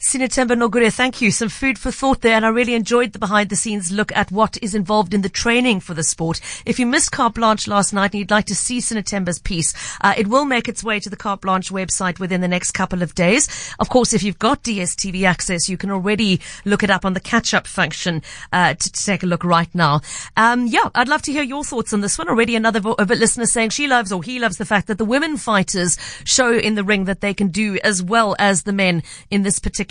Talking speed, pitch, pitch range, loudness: 260 wpm, 210 Hz, 190-230 Hz, -18 LUFS